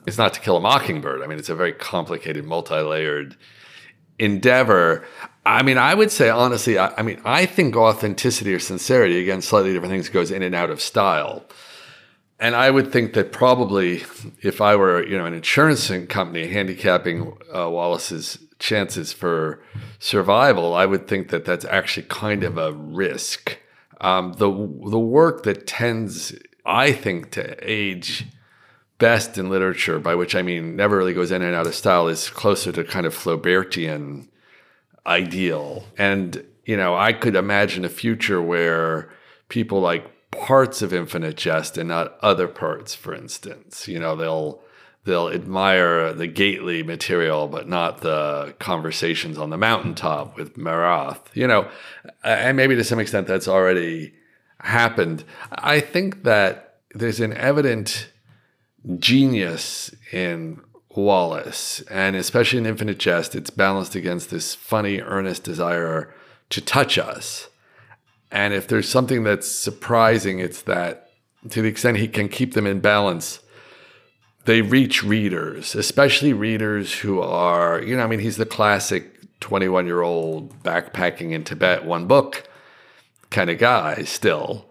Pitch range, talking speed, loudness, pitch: 85-115 Hz, 150 wpm, -20 LUFS, 95 Hz